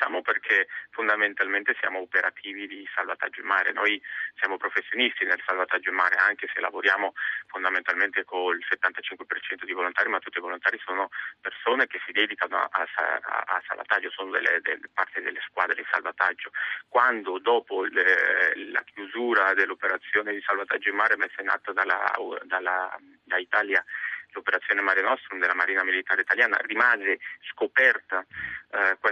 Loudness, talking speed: -25 LUFS, 145 wpm